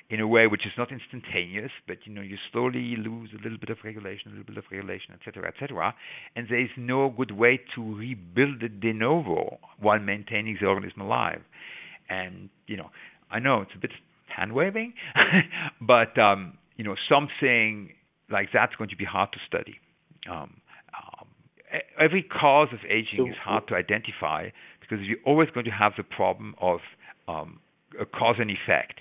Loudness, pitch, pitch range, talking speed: -25 LUFS, 115 Hz, 105-125 Hz, 185 wpm